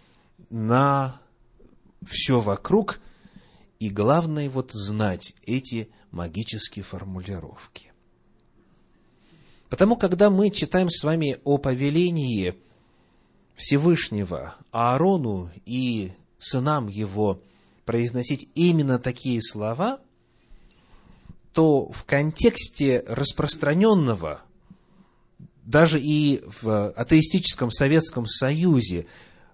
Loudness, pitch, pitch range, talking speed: -23 LUFS, 130 Hz, 110-155 Hz, 75 wpm